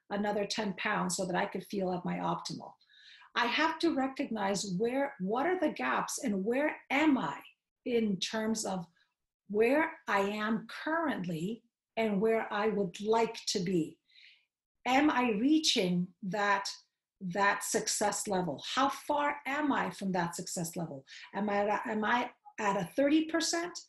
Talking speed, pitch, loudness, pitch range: 155 wpm, 220 Hz, -32 LUFS, 200-275 Hz